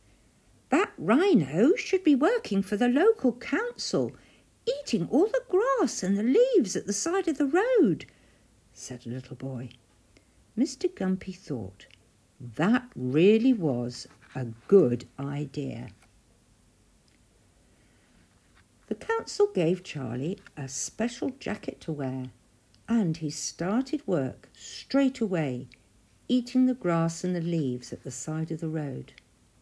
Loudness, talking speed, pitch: -27 LUFS, 125 wpm, 165 Hz